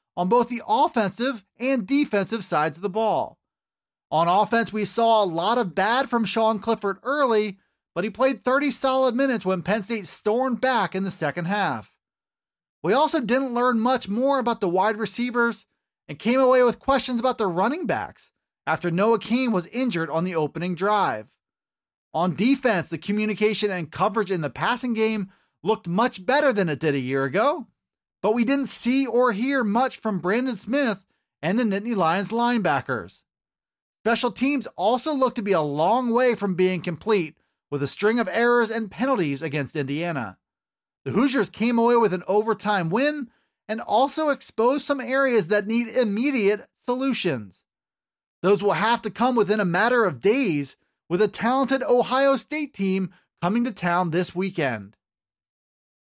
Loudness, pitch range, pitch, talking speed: -23 LUFS, 190-250 Hz, 220 Hz, 170 wpm